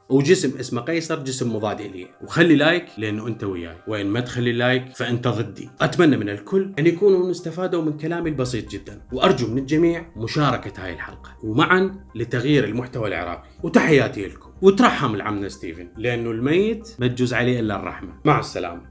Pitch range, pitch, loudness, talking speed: 105-160 Hz, 125 Hz, -21 LUFS, 160 wpm